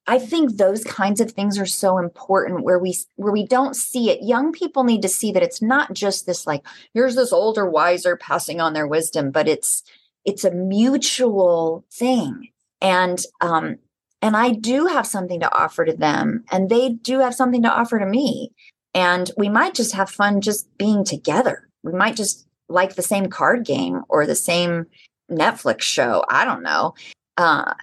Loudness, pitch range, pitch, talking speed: -19 LUFS, 180-250 Hz, 205 Hz, 190 wpm